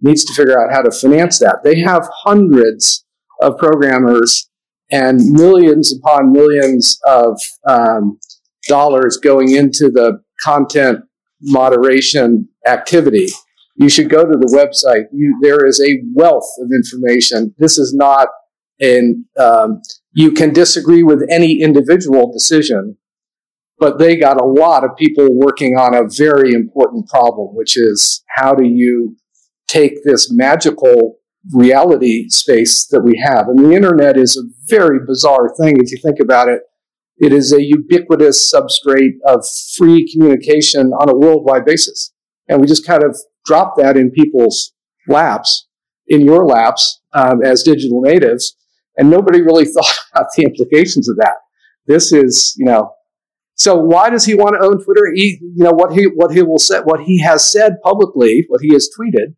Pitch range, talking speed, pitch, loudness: 130-175 Hz, 160 wpm, 150 Hz, -10 LUFS